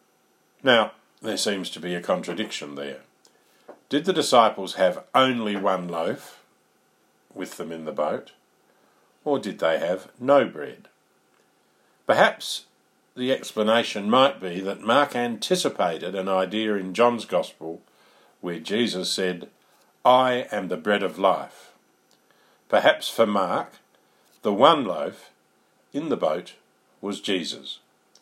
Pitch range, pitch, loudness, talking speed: 90-120 Hz, 100 Hz, -24 LUFS, 125 wpm